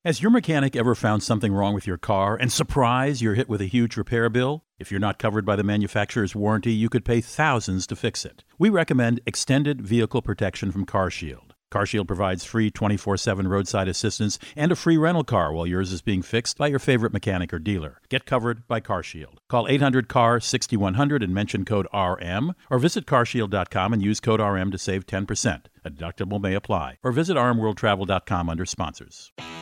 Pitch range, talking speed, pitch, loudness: 95-125 Hz, 190 wpm, 110 Hz, -23 LUFS